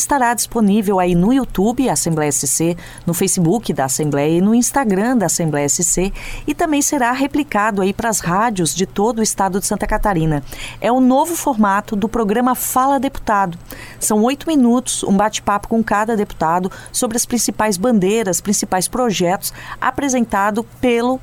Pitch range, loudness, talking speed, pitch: 185-245 Hz, -16 LUFS, 160 wpm, 210 Hz